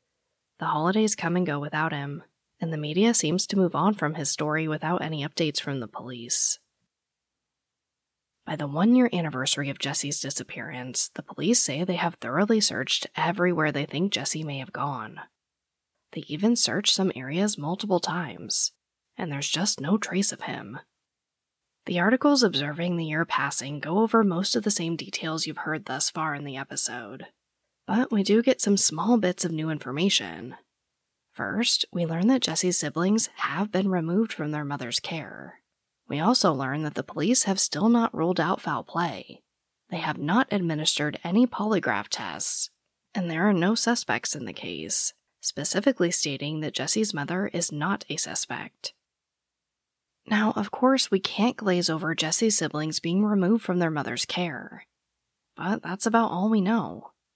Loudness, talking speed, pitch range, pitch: -25 LUFS, 165 wpm, 150-205 Hz, 175 Hz